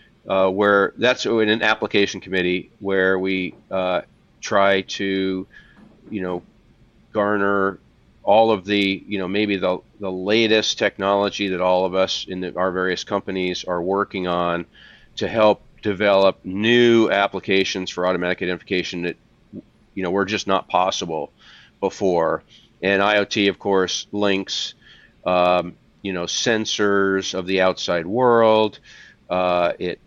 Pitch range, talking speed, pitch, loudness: 90-105 Hz, 135 wpm, 95 Hz, -20 LUFS